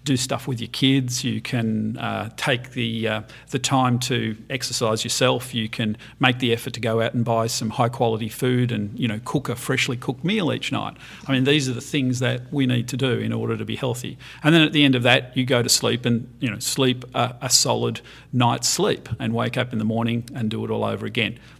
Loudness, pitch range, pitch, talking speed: -22 LUFS, 115-130 Hz, 120 Hz, 245 wpm